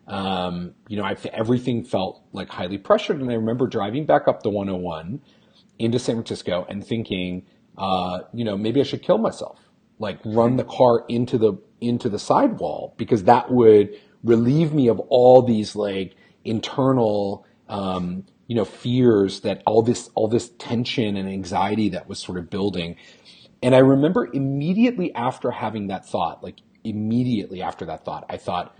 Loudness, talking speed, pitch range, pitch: -21 LUFS, 170 wpm, 100-125 Hz, 110 Hz